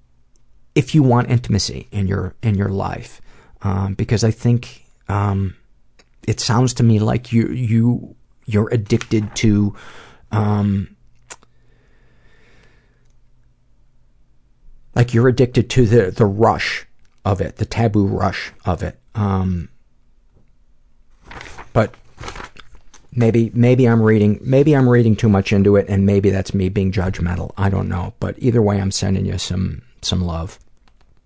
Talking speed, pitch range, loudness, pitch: 135 wpm, 95-120 Hz, -18 LUFS, 105 Hz